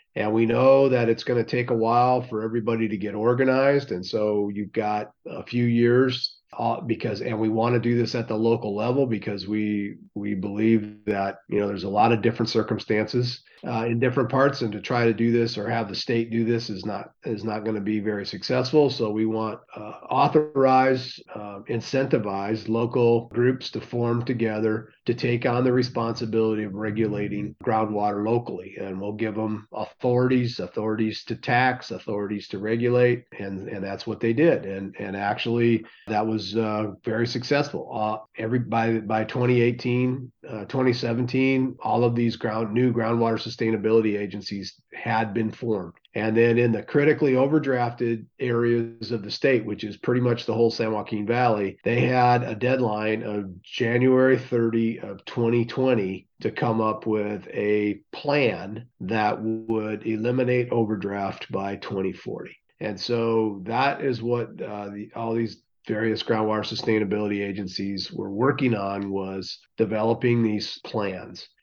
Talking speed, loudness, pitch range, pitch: 165 wpm, -24 LUFS, 105-120 Hz, 115 Hz